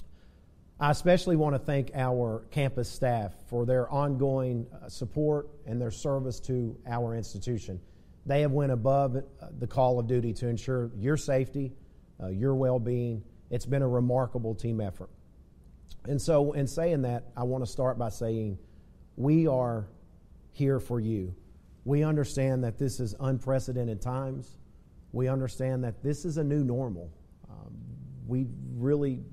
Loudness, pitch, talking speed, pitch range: -30 LUFS, 125 Hz, 150 wpm, 110-135 Hz